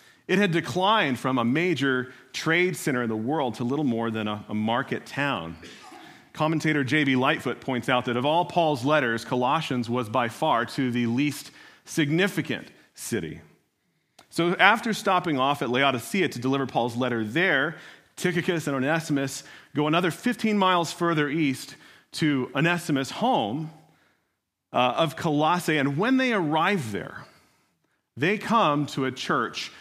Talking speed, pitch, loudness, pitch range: 145 wpm, 150 Hz, -25 LUFS, 125-170 Hz